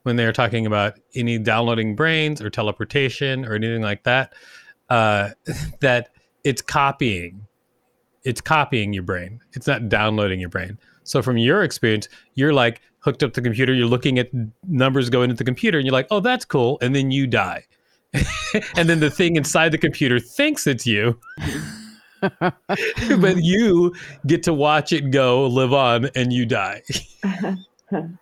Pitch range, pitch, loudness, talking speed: 115-155 Hz, 130 Hz, -20 LUFS, 165 wpm